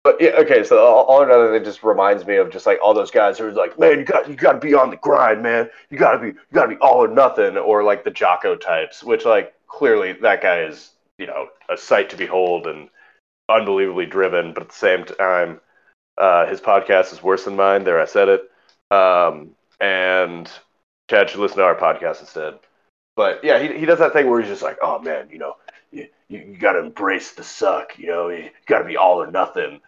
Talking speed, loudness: 245 wpm, -17 LUFS